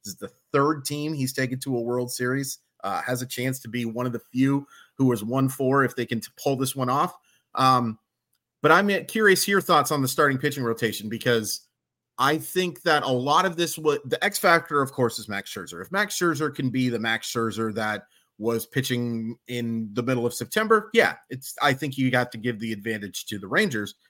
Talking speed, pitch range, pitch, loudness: 225 wpm, 115-150 Hz, 130 Hz, -24 LUFS